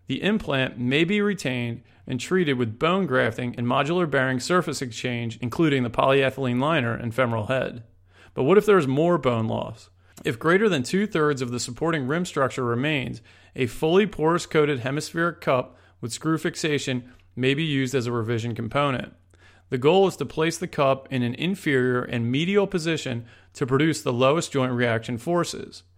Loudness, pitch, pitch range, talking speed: -24 LUFS, 130 Hz, 120-160 Hz, 180 wpm